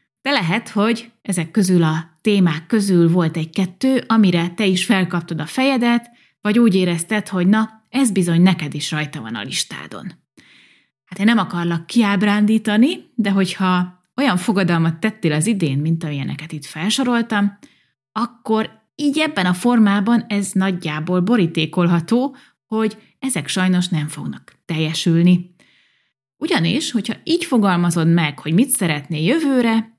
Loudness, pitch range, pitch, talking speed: -18 LUFS, 170-230 Hz, 195 Hz, 135 wpm